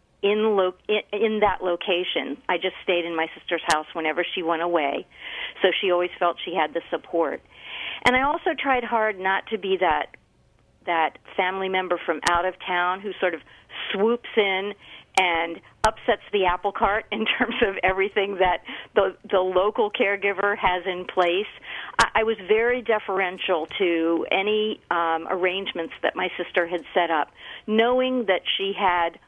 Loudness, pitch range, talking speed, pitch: -24 LUFS, 175-210 Hz, 165 wpm, 190 Hz